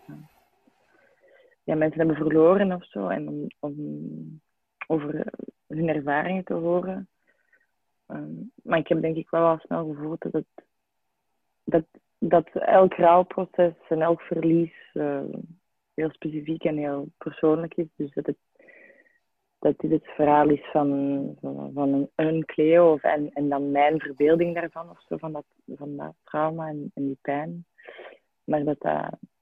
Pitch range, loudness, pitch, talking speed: 145-170 Hz, -25 LUFS, 160 Hz, 150 wpm